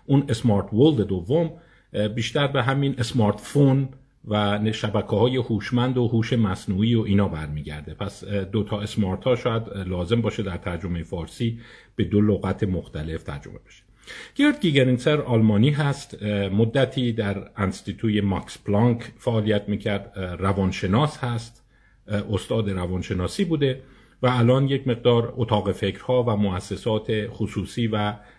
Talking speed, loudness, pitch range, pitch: 130 wpm, -23 LUFS, 100-125 Hz, 110 Hz